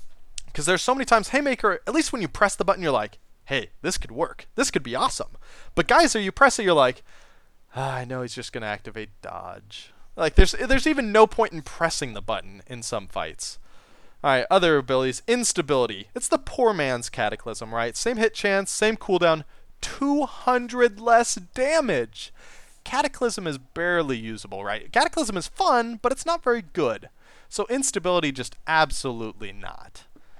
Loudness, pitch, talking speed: -23 LUFS, 185 Hz, 175 wpm